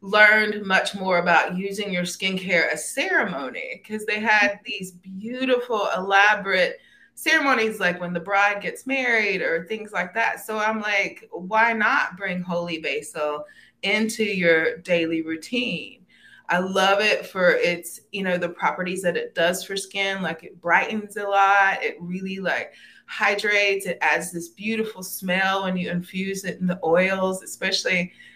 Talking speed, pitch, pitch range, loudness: 155 wpm, 195 Hz, 180-215 Hz, -22 LUFS